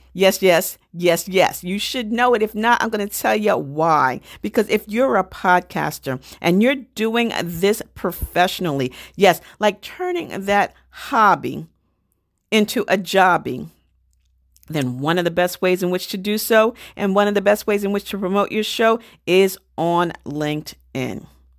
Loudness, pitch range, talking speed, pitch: -19 LUFS, 165-215 Hz, 165 wpm, 190 Hz